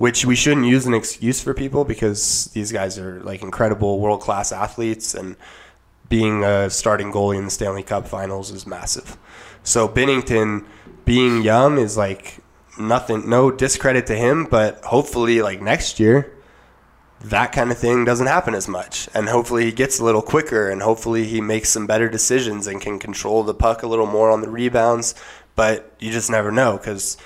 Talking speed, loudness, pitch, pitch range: 185 wpm, -19 LUFS, 110 Hz, 105-120 Hz